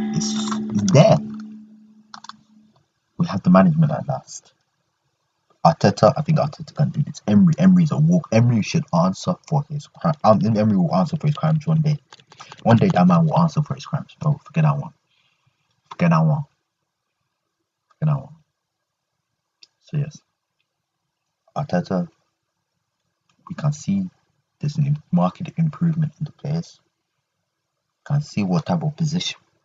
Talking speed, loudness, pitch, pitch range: 150 wpm, -20 LUFS, 160 Hz, 150-175 Hz